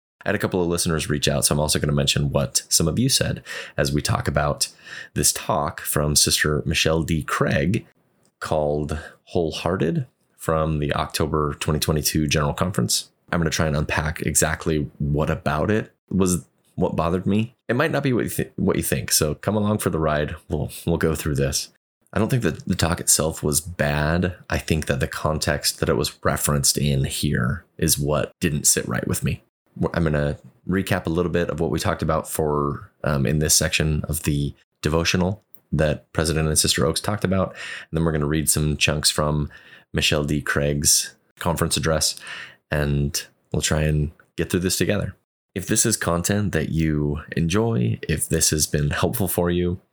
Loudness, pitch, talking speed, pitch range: -22 LUFS, 80 Hz, 195 wpm, 75-90 Hz